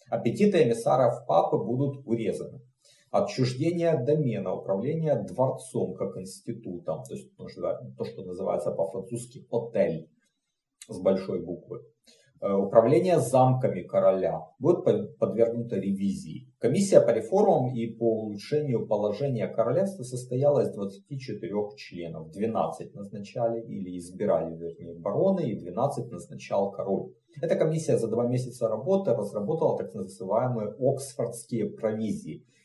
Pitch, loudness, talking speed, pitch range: 115 Hz, -27 LUFS, 110 wpm, 100-140 Hz